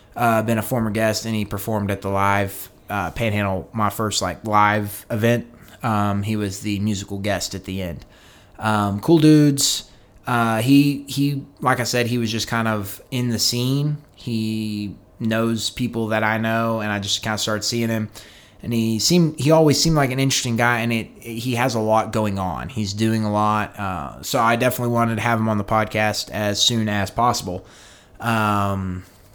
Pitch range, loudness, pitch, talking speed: 105-120 Hz, -20 LUFS, 110 Hz, 200 wpm